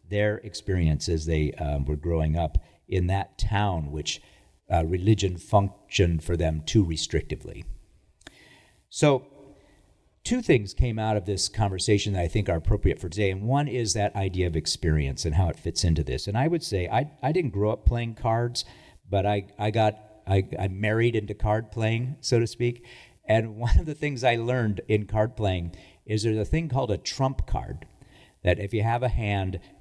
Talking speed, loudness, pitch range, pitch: 190 wpm, -26 LUFS, 85-115 Hz, 105 Hz